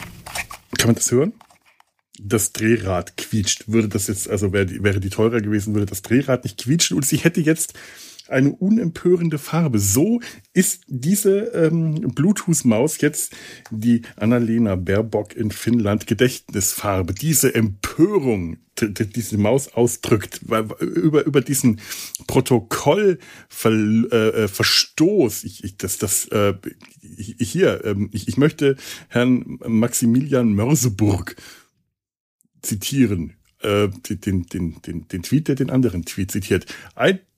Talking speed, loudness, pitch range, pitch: 125 wpm, -20 LUFS, 105-140 Hz, 115 Hz